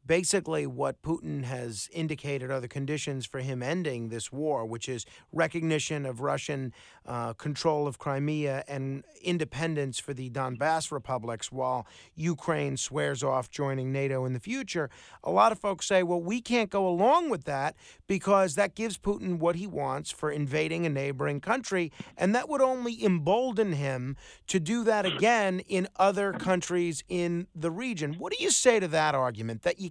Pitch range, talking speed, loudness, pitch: 135-190 Hz, 175 wpm, -29 LUFS, 155 Hz